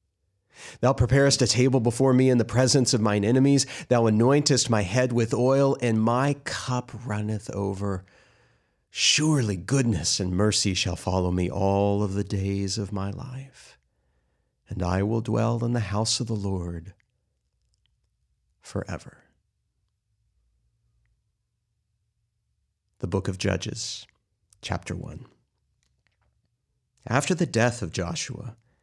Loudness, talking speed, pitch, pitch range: -24 LUFS, 125 wpm, 110 Hz, 100-125 Hz